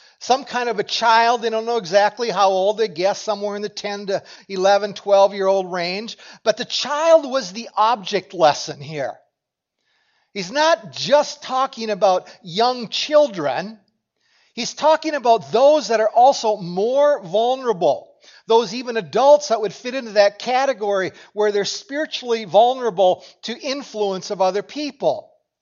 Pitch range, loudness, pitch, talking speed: 200-265 Hz, -19 LUFS, 225 Hz, 150 wpm